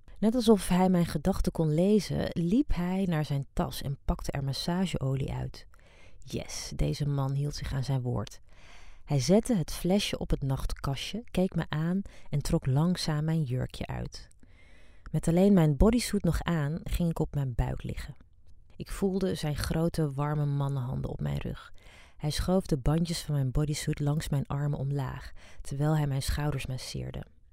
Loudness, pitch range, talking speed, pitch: -30 LUFS, 135-175 Hz, 170 wpm, 150 Hz